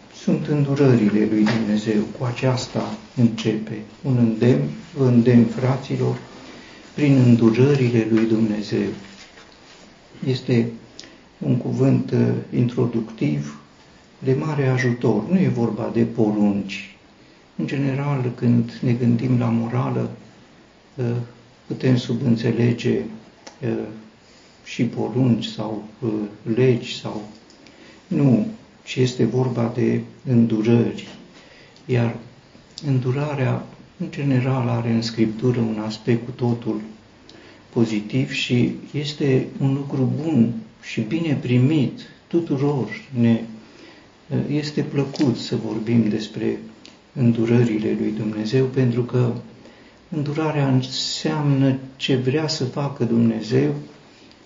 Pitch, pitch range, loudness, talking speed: 120 Hz, 110-130 Hz, -21 LUFS, 100 wpm